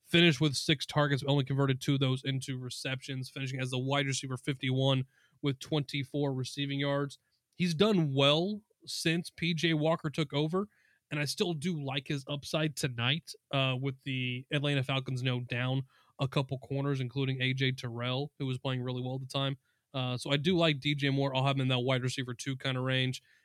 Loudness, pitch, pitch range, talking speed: -32 LUFS, 140 Hz, 130-150 Hz, 200 wpm